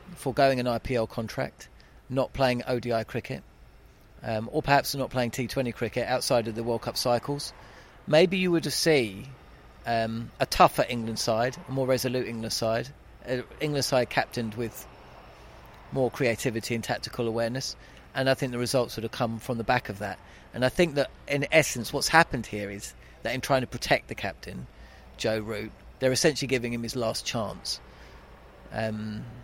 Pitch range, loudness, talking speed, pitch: 115-130 Hz, -28 LUFS, 175 wpm, 120 Hz